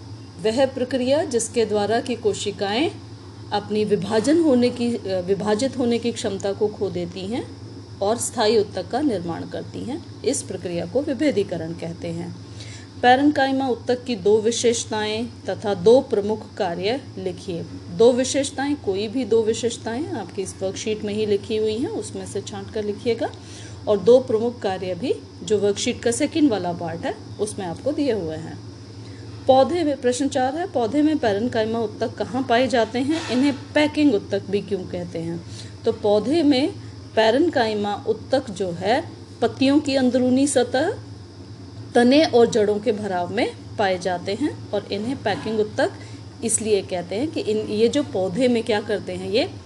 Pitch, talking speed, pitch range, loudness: 225 Hz, 165 wpm, 200-255 Hz, -22 LUFS